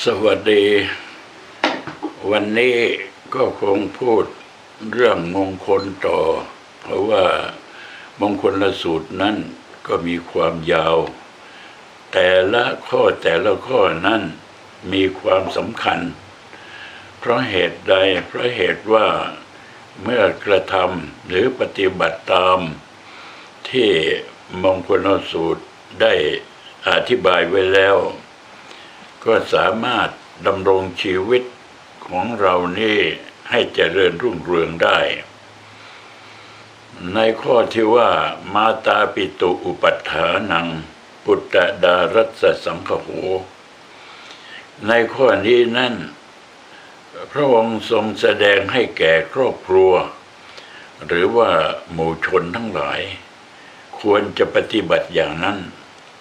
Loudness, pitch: -17 LUFS, 115 Hz